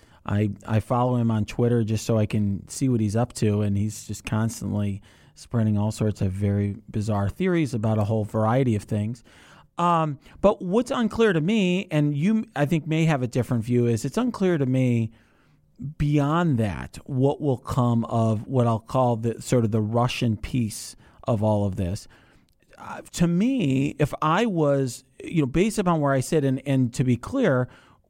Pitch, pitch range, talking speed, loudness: 120 Hz, 110-145 Hz, 190 wpm, -24 LUFS